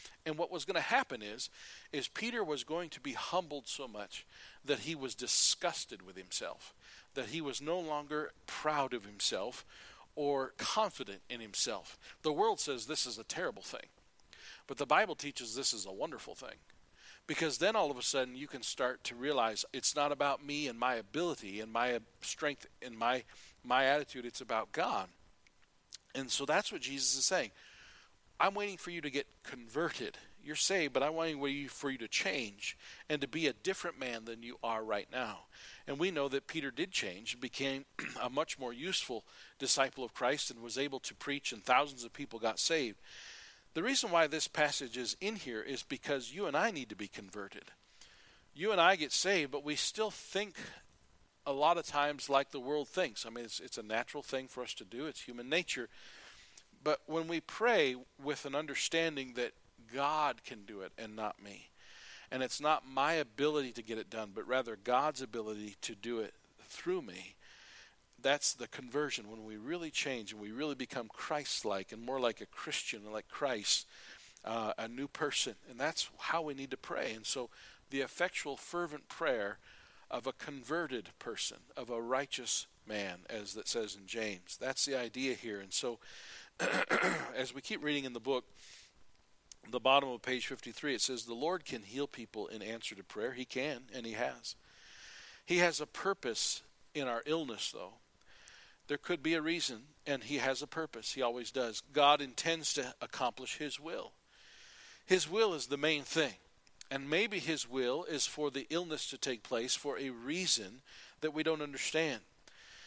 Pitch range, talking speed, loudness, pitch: 120-155 Hz, 190 wpm, -36 LUFS, 140 Hz